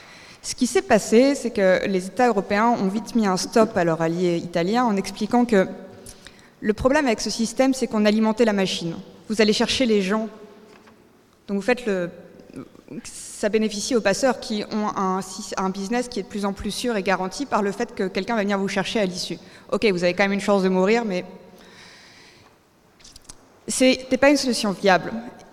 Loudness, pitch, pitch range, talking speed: -22 LUFS, 210 Hz, 190-230 Hz, 195 wpm